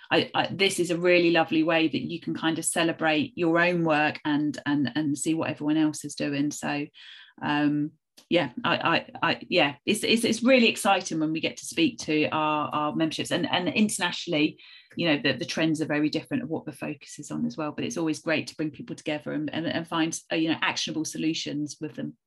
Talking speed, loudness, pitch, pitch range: 230 wpm, -26 LUFS, 160 Hz, 150-170 Hz